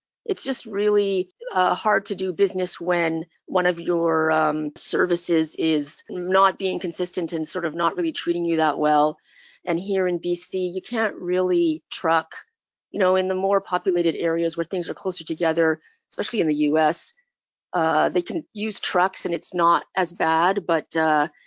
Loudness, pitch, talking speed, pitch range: -22 LUFS, 175 Hz, 175 wpm, 165-190 Hz